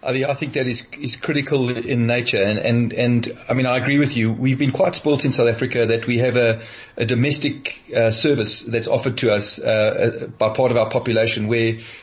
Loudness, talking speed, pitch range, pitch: -19 LUFS, 225 wpm, 115-135 Hz, 120 Hz